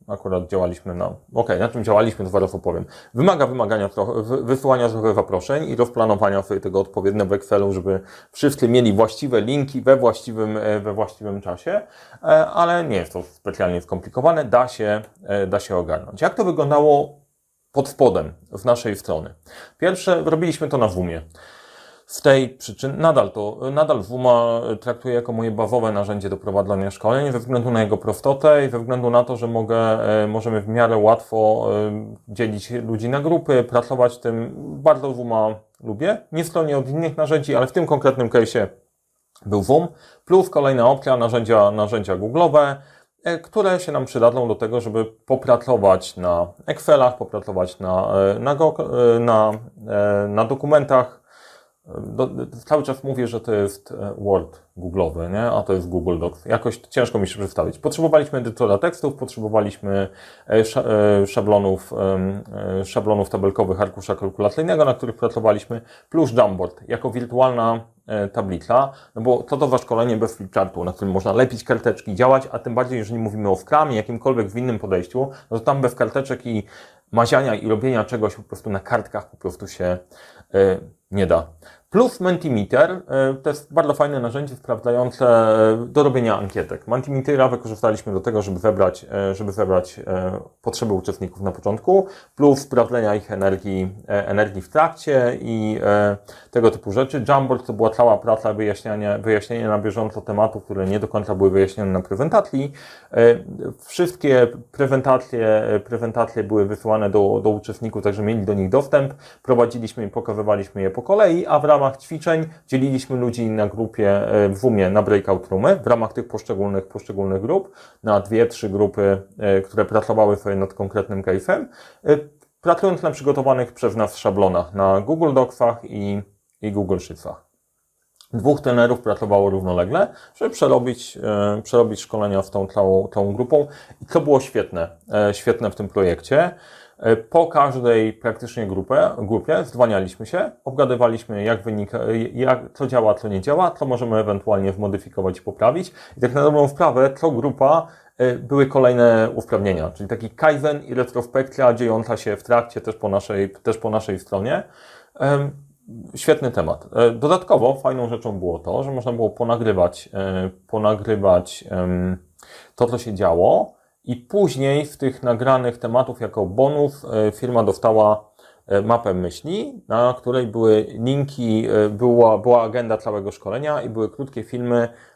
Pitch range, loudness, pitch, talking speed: 100-130 Hz, -19 LUFS, 115 Hz, 150 wpm